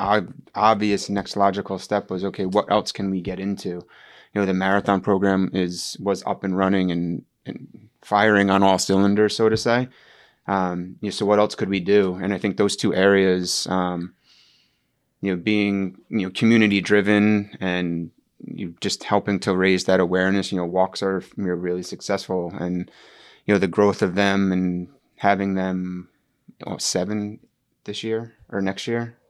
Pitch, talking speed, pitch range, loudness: 95 Hz, 175 wpm, 95-105 Hz, -22 LUFS